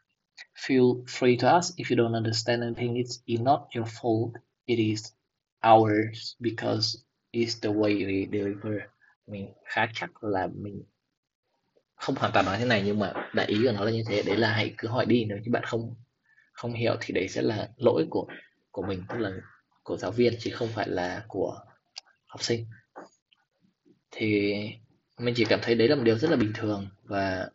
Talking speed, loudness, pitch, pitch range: 195 wpm, -27 LUFS, 115 Hz, 105-120 Hz